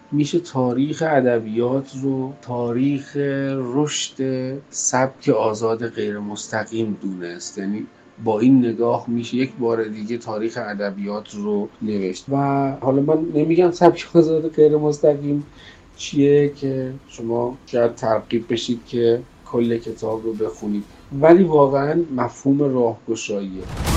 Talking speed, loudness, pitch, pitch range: 115 wpm, -20 LUFS, 120 Hz, 110-140 Hz